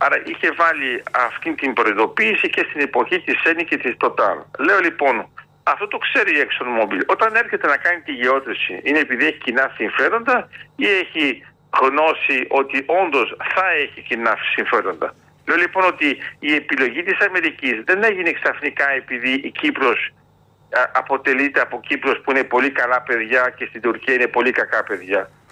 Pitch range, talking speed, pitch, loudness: 125-190 Hz, 160 wpm, 140 Hz, -18 LUFS